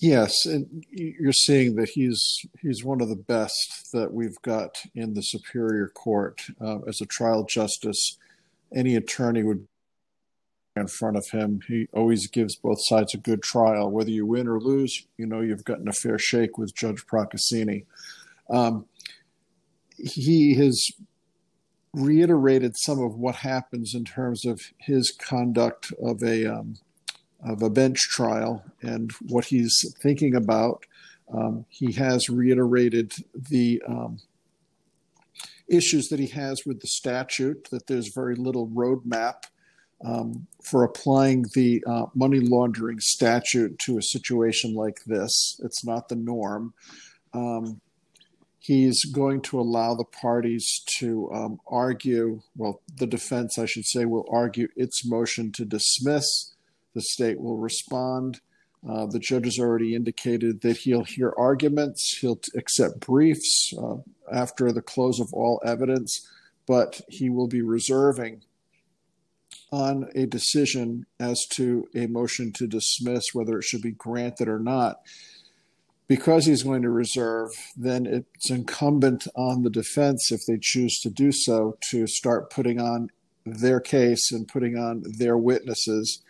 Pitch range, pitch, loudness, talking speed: 115-130 Hz, 120 Hz, -24 LUFS, 145 wpm